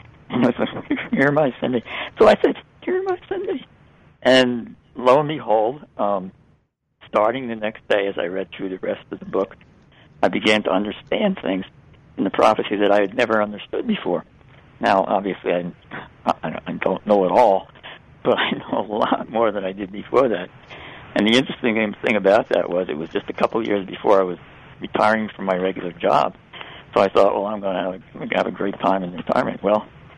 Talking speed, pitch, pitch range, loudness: 205 wpm, 105 Hz, 95-120 Hz, -21 LUFS